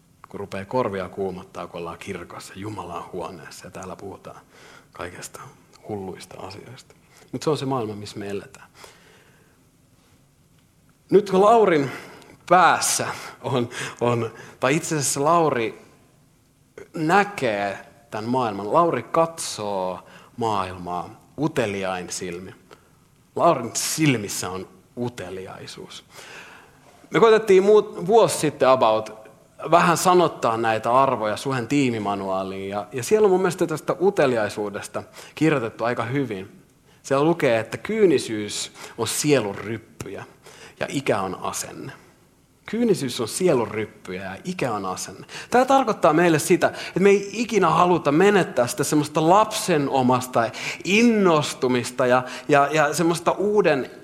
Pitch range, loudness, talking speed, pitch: 110-170 Hz, -21 LUFS, 115 wpm, 130 Hz